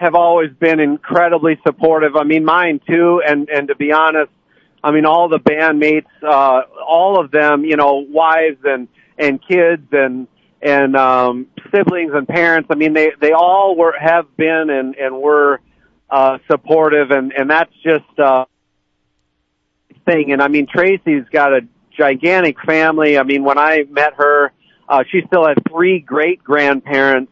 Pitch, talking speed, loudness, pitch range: 150 Hz, 165 wpm, -13 LUFS, 140-165 Hz